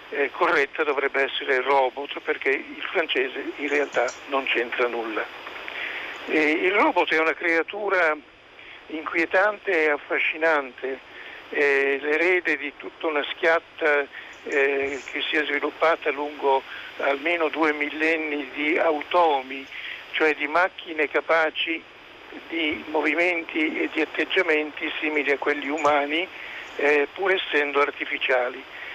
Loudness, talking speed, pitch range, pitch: -23 LUFS, 115 wpm, 145-170 Hz, 155 Hz